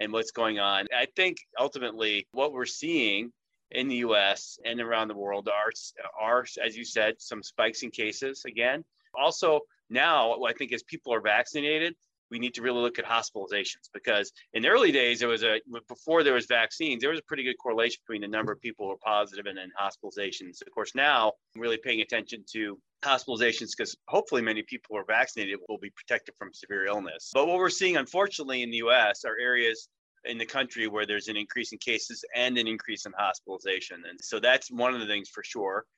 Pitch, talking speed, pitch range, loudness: 120 Hz, 210 wpm, 110-135 Hz, -28 LUFS